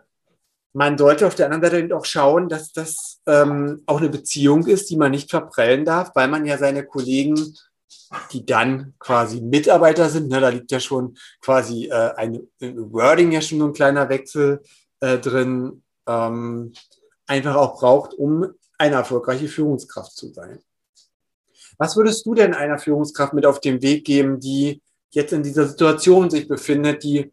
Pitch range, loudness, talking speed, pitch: 135-155 Hz, -18 LUFS, 170 wpm, 145 Hz